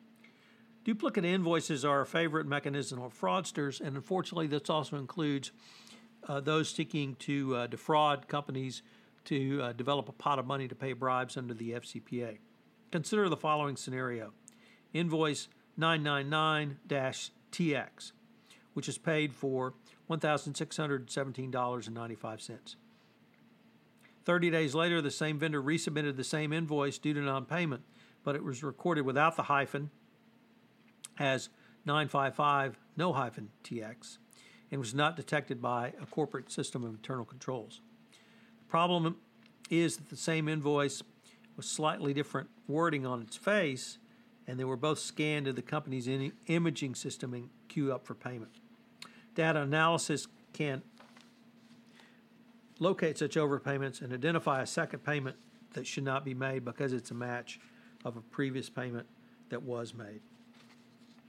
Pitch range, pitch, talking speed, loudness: 135-175 Hz, 150 Hz, 135 wpm, -34 LUFS